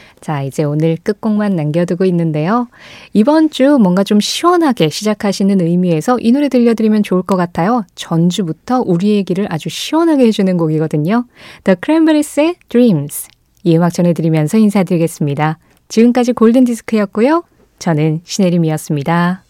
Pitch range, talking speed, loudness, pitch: 165-235 Hz, 405 characters per minute, -13 LUFS, 195 Hz